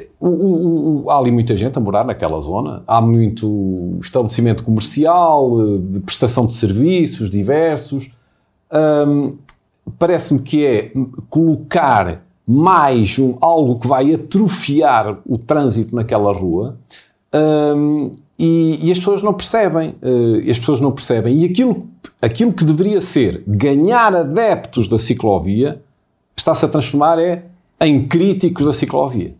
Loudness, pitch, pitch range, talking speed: -15 LUFS, 145 Hz, 115-165 Hz, 125 wpm